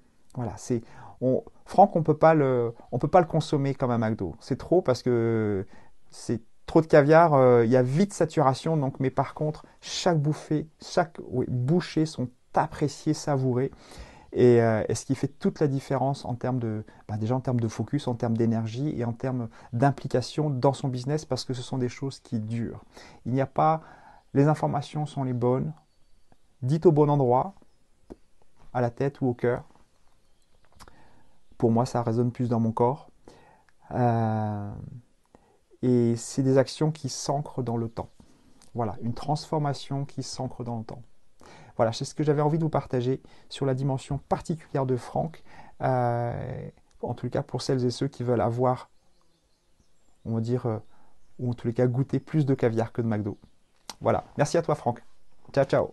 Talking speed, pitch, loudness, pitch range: 180 wpm, 130 Hz, -26 LUFS, 120-145 Hz